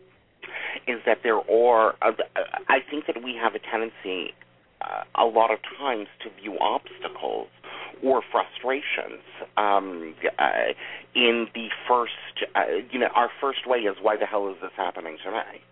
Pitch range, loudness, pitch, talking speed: 100-125 Hz, -25 LUFS, 115 Hz, 155 wpm